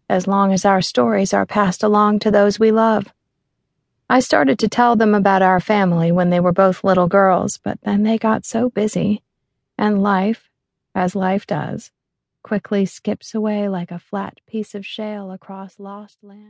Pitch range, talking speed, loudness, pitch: 190-215 Hz, 180 wpm, -17 LUFS, 205 Hz